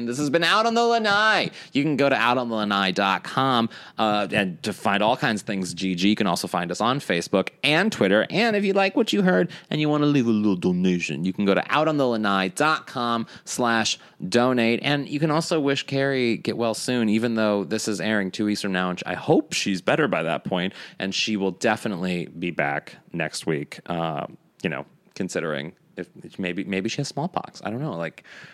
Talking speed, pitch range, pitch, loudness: 210 wpm, 100-145 Hz, 115 Hz, -23 LUFS